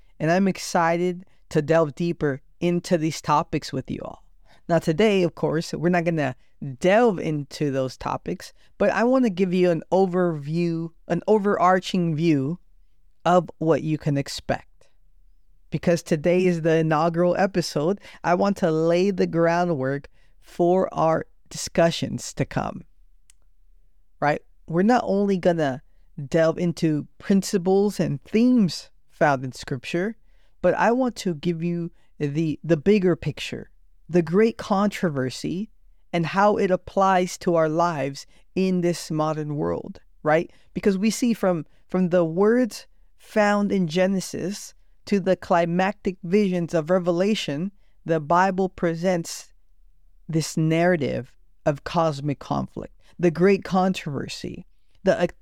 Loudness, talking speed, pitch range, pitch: -23 LUFS, 130 wpm, 155-185 Hz, 175 Hz